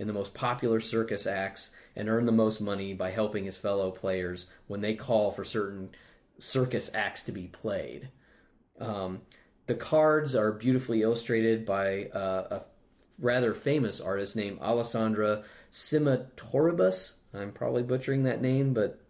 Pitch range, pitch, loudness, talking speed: 100-120 Hz, 110 Hz, -30 LUFS, 150 wpm